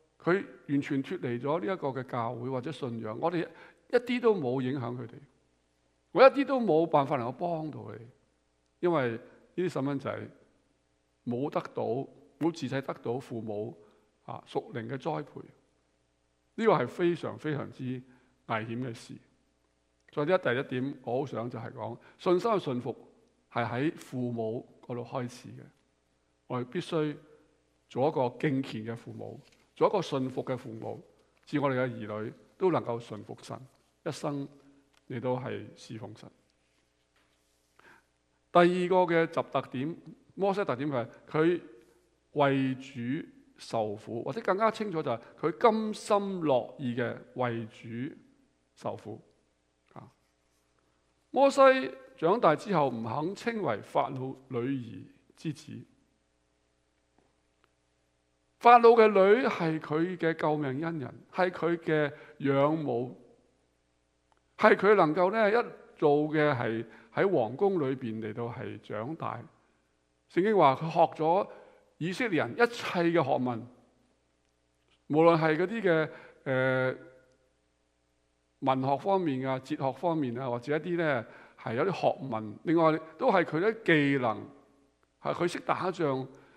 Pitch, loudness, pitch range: 130 Hz, -29 LUFS, 110-165 Hz